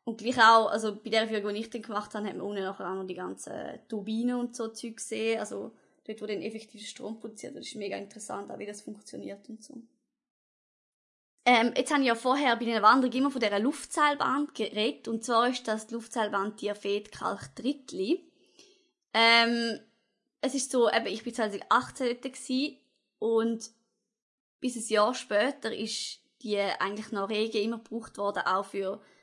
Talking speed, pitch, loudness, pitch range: 180 wpm, 225 Hz, -29 LUFS, 215-250 Hz